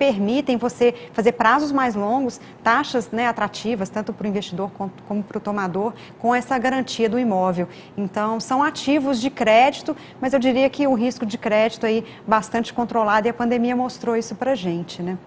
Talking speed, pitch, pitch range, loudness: 185 wpm, 230 Hz, 210-255 Hz, -21 LUFS